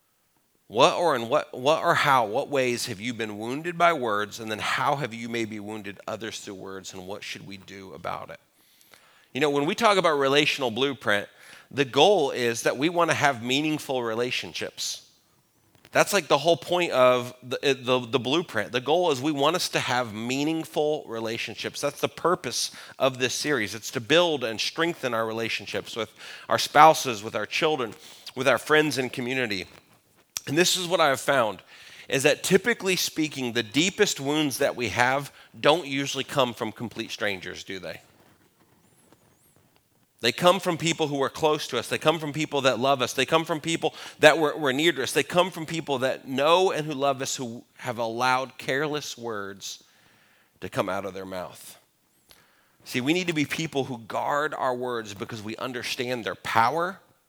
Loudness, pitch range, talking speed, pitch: -25 LUFS, 115-155 Hz, 190 wpm, 135 Hz